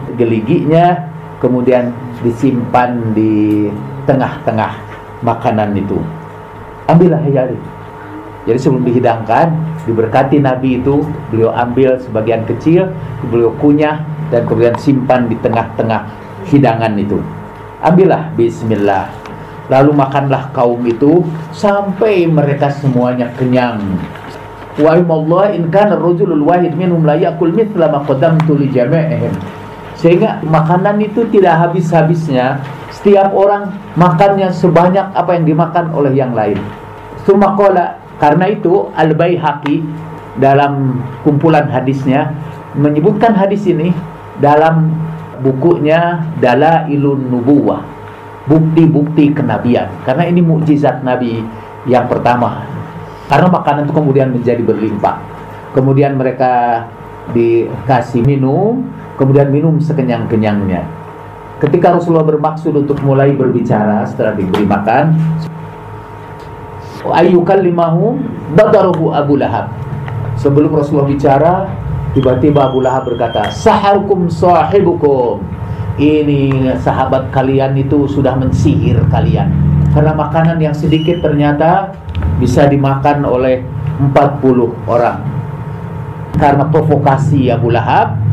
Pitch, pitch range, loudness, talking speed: 145 Hz, 120-160 Hz, -12 LUFS, 95 wpm